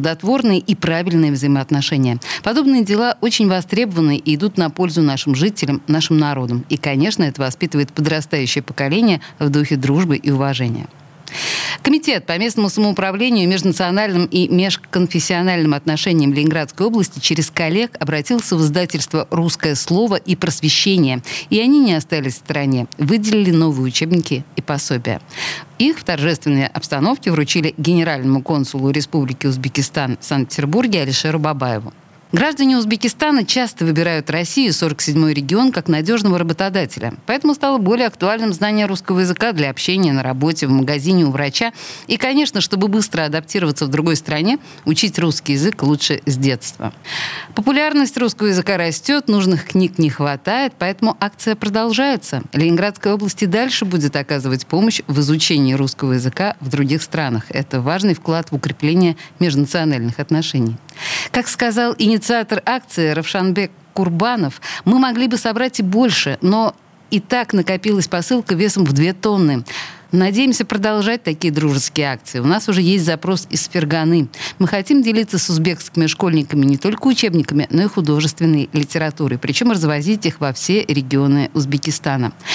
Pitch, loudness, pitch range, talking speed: 165 Hz, -17 LUFS, 145-205 Hz, 140 wpm